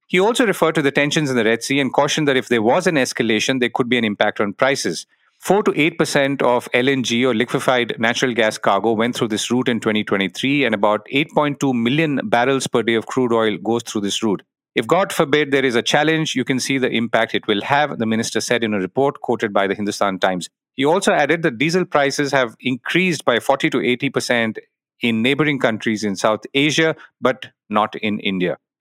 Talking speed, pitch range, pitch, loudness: 220 wpm, 110-140 Hz, 125 Hz, -18 LUFS